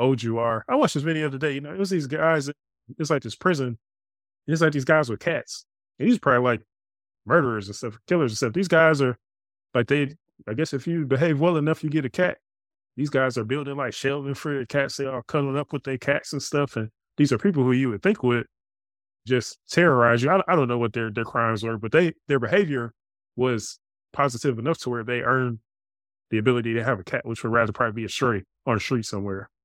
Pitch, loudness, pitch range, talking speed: 130 Hz, -24 LUFS, 115-150 Hz, 245 wpm